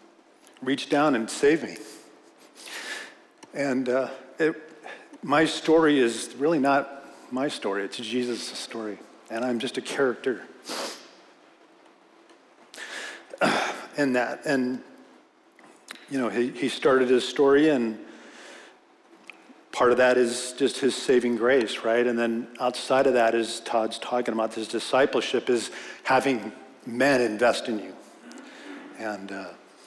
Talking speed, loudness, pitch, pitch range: 125 wpm, -25 LUFS, 130 Hz, 120-155 Hz